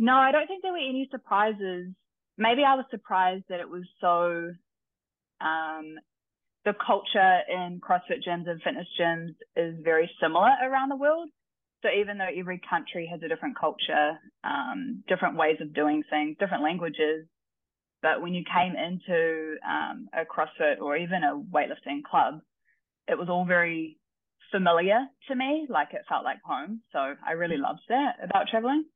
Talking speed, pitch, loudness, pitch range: 165 wpm, 180 Hz, -27 LUFS, 165-240 Hz